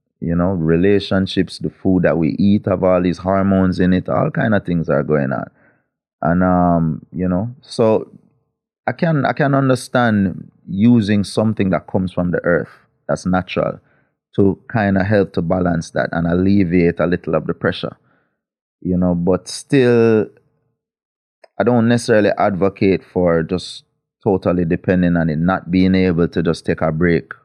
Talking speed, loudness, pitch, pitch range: 165 wpm, -17 LUFS, 95 Hz, 85-100 Hz